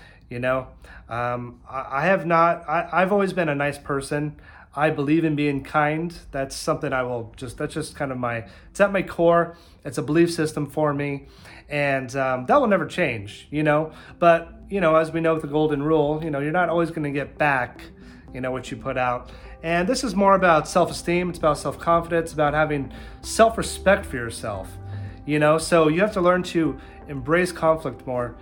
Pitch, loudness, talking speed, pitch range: 150 Hz, -22 LUFS, 205 wpm, 135-170 Hz